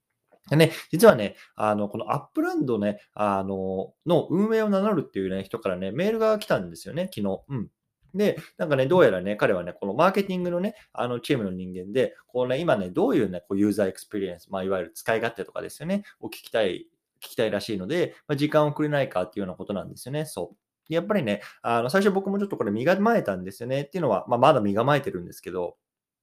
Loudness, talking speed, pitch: -25 LUFS, 480 characters per minute, 135 Hz